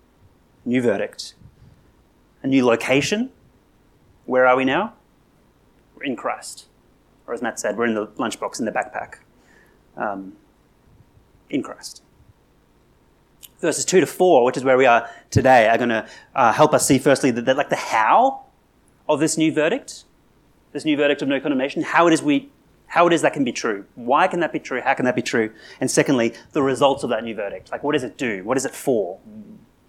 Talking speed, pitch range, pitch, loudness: 195 wpm, 125-165 Hz, 140 Hz, -20 LUFS